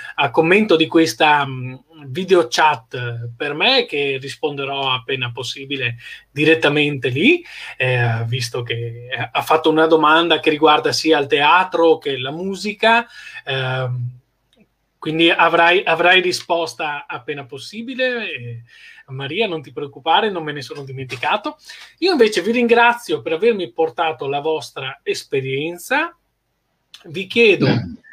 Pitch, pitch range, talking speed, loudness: 155 Hz, 135-185 Hz, 125 wpm, -17 LUFS